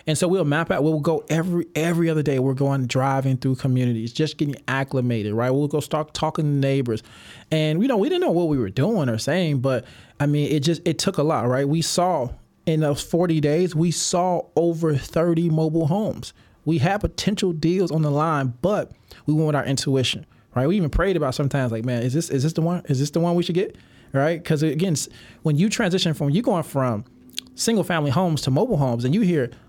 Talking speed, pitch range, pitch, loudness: 230 wpm, 135-170 Hz, 155 Hz, -22 LUFS